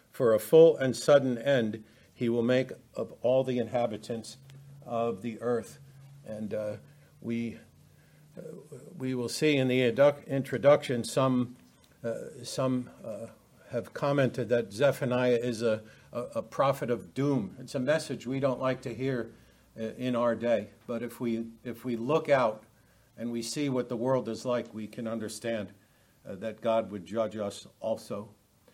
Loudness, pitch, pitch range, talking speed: -30 LUFS, 120 Hz, 115-135 Hz, 165 wpm